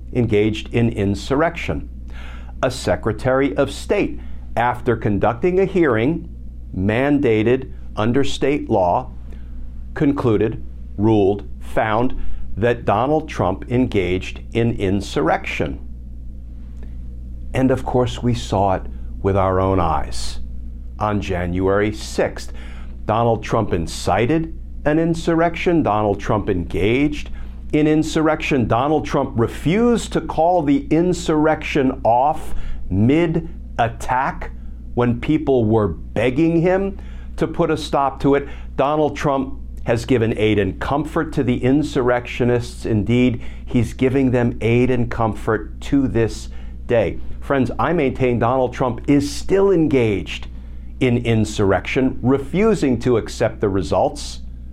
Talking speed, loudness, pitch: 115 wpm, -19 LUFS, 115 Hz